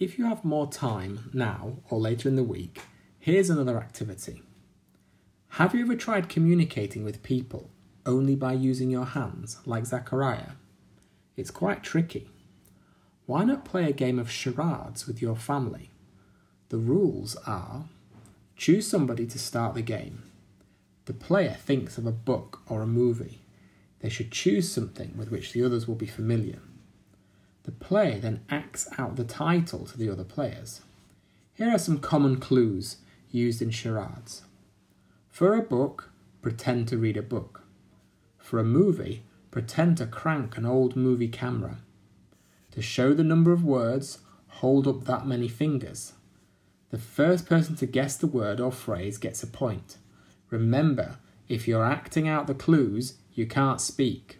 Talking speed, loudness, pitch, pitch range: 155 wpm, -27 LUFS, 120 Hz, 110-140 Hz